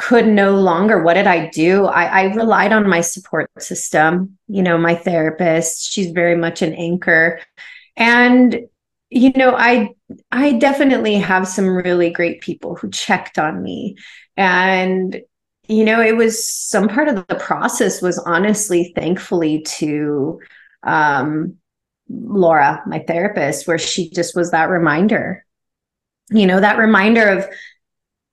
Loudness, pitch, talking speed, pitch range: -15 LUFS, 190 Hz, 140 wpm, 170-225 Hz